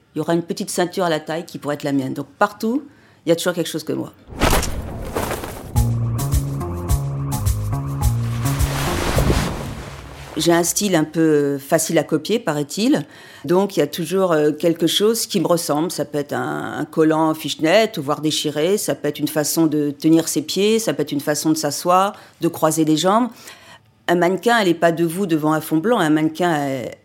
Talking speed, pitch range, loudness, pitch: 190 wpm, 145-175 Hz, -19 LUFS, 155 Hz